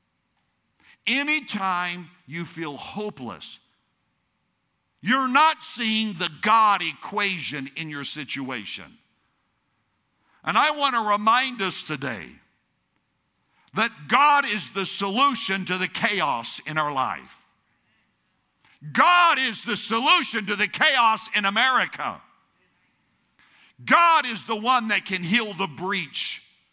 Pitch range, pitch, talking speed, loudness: 180-255 Hz, 210 Hz, 110 wpm, -22 LUFS